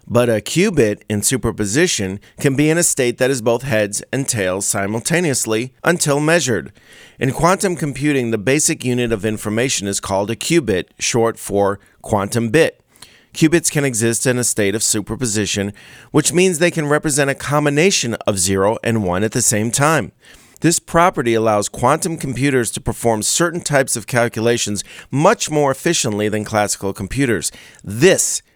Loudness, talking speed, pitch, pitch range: -17 LUFS, 160 wpm, 120 Hz, 105-150 Hz